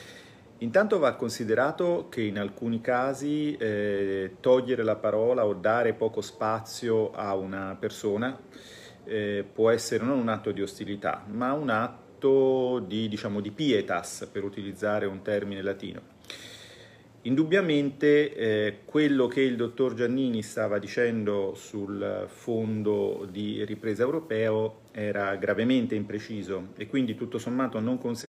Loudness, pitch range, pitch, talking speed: -28 LUFS, 105-125 Hz, 110 Hz, 125 wpm